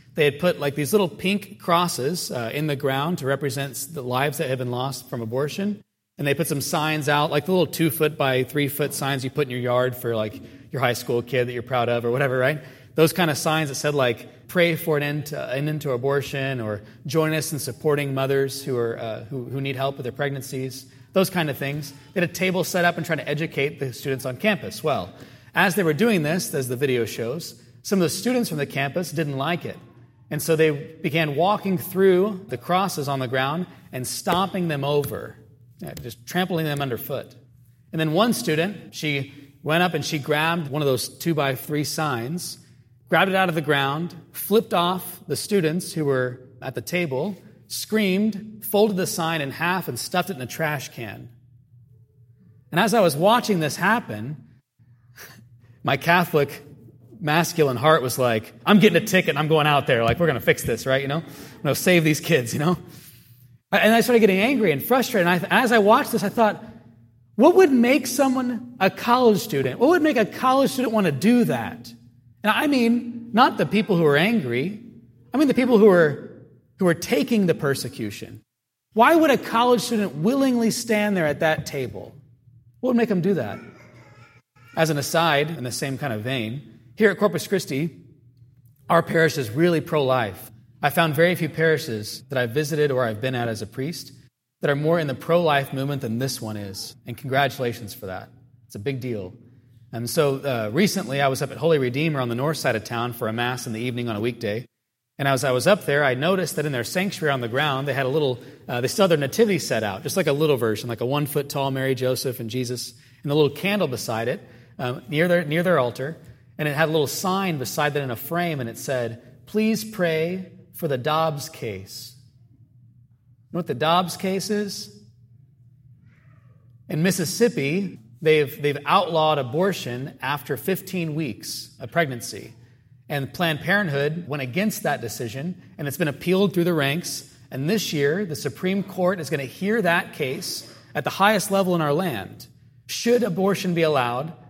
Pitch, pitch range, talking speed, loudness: 145 Hz, 125-175 Hz, 205 wpm, -22 LUFS